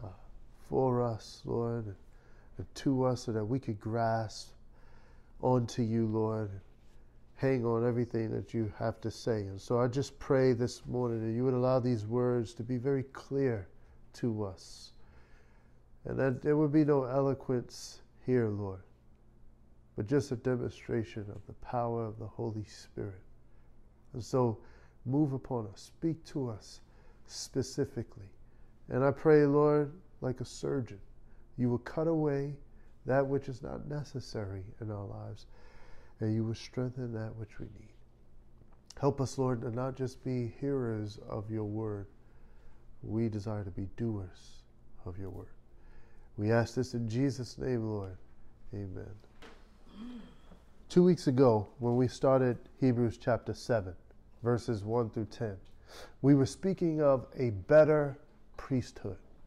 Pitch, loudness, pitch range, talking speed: 120 Hz, -33 LUFS, 110-130 Hz, 145 wpm